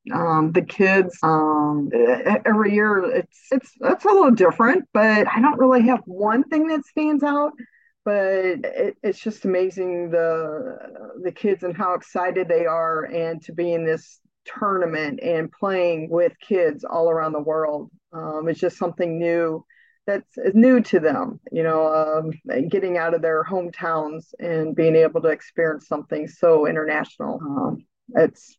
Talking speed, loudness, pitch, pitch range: 160 wpm, -21 LUFS, 180 Hz, 160-220 Hz